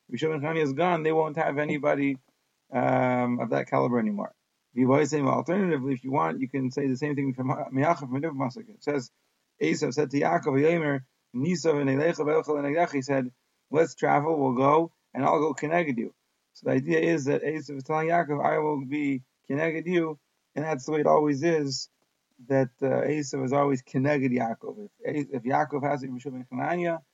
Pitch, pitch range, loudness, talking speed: 145 Hz, 135-155 Hz, -27 LUFS, 190 wpm